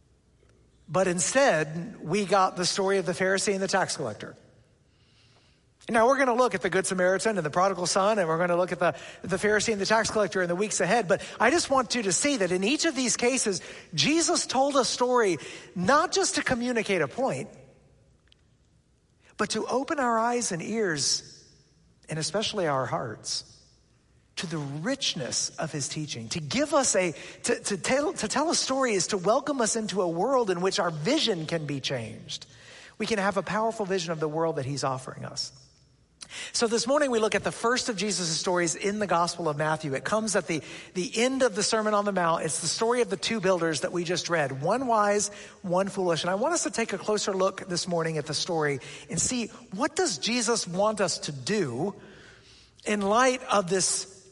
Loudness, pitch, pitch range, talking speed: -26 LUFS, 195 Hz, 175-230 Hz, 210 wpm